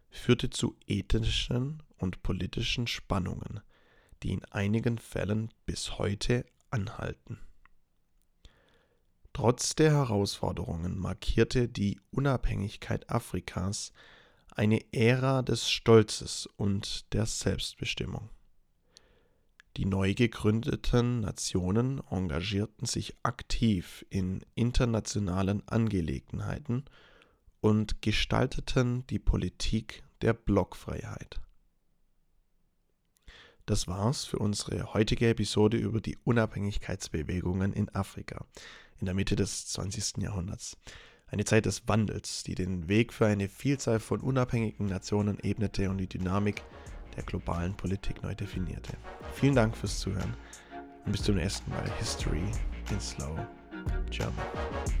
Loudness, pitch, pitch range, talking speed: -31 LUFS, 105 Hz, 95-115 Hz, 105 wpm